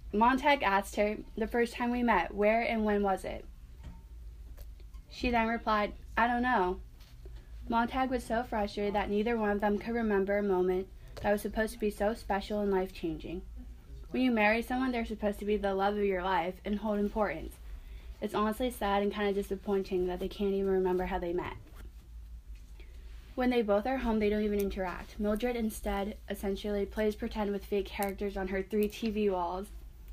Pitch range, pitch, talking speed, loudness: 185-215 Hz, 205 Hz, 190 wpm, -32 LUFS